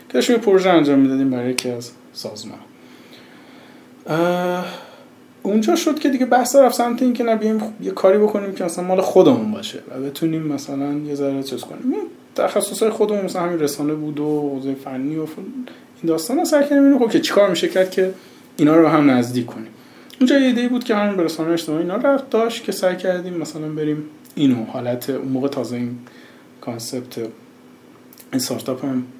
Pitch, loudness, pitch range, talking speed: 175 Hz, -19 LUFS, 140-220 Hz, 175 wpm